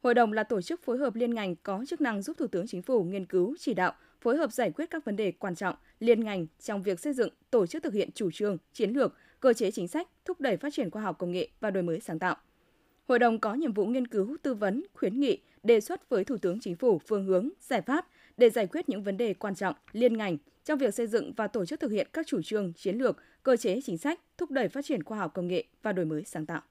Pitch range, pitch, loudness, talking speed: 190-280 Hz, 230 Hz, -30 LUFS, 280 wpm